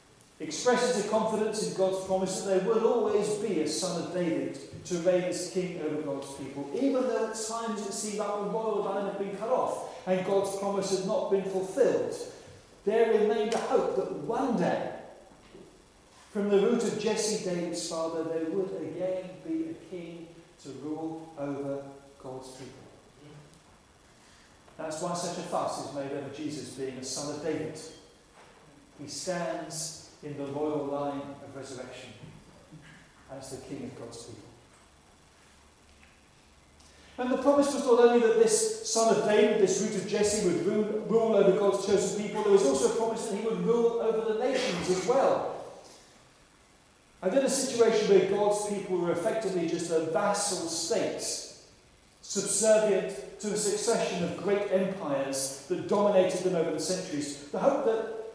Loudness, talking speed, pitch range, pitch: -29 LUFS, 165 wpm, 160-215 Hz, 190 Hz